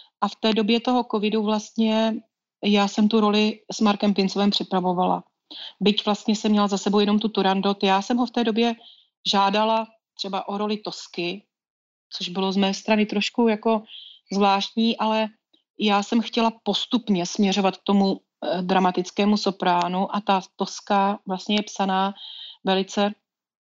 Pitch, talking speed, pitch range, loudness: 205 Hz, 150 wpm, 195-220 Hz, -23 LUFS